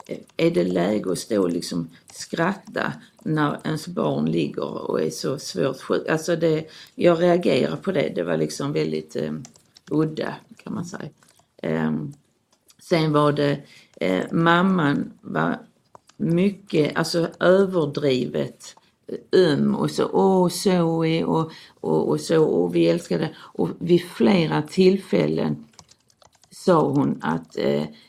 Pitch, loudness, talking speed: 160 Hz, -22 LUFS, 130 wpm